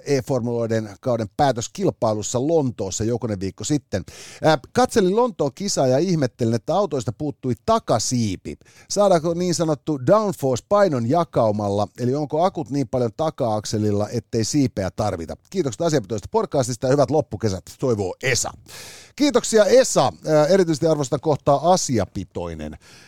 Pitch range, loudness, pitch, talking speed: 115-165 Hz, -21 LUFS, 135 Hz, 115 wpm